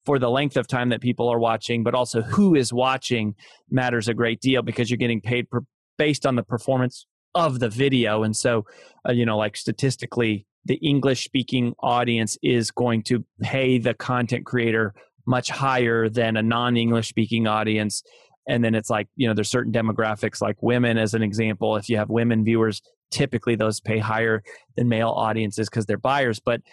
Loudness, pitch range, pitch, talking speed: -23 LUFS, 110-125 Hz, 120 Hz, 195 wpm